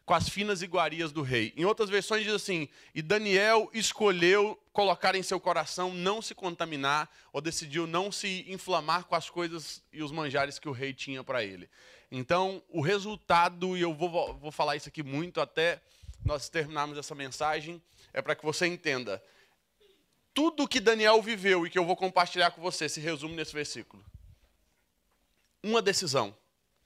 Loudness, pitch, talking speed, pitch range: -30 LUFS, 170 Hz, 170 wpm, 150-190 Hz